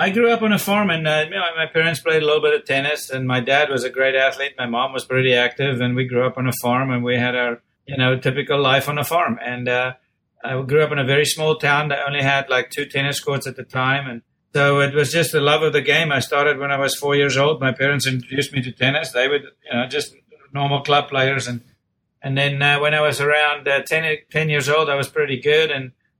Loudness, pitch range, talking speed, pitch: -19 LUFS, 130-150 Hz, 270 wpm, 140 Hz